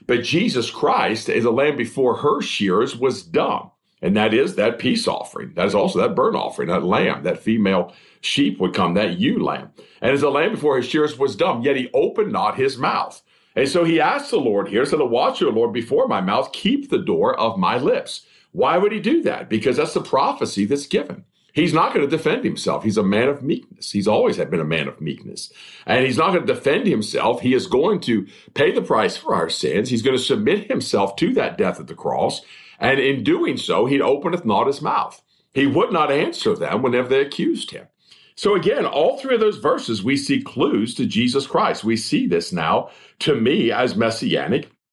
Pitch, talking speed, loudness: 205 Hz, 220 wpm, -20 LUFS